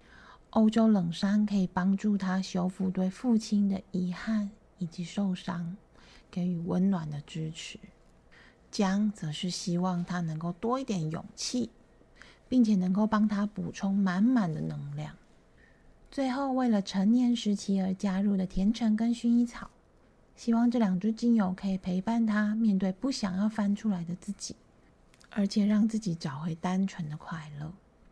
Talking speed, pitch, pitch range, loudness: 230 characters per minute, 195 Hz, 180-215 Hz, -30 LUFS